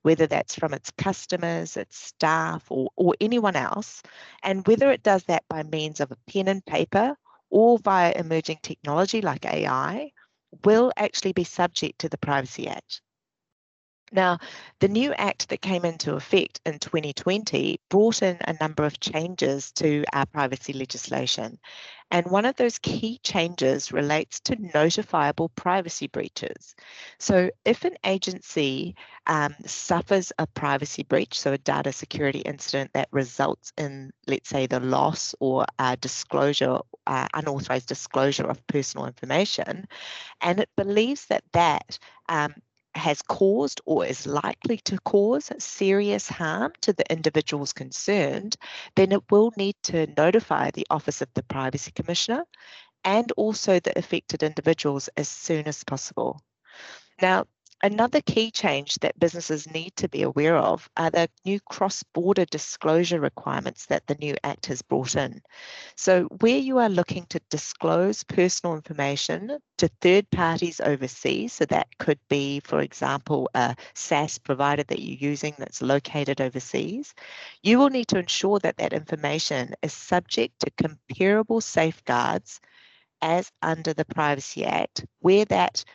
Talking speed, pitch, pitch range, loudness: 145 wpm, 165 Hz, 145-200 Hz, -25 LUFS